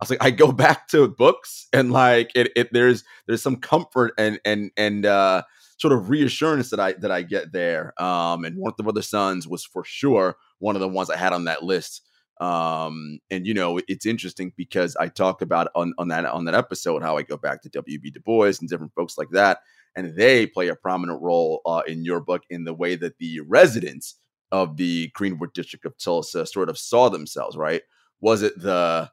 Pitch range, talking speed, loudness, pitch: 85-115 Hz, 220 wpm, -22 LUFS, 95 Hz